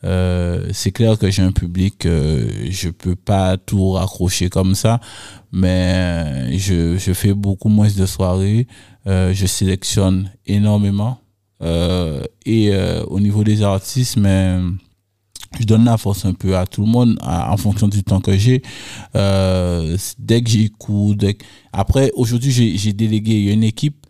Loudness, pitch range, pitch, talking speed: -17 LUFS, 95-110 Hz, 100 Hz, 165 wpm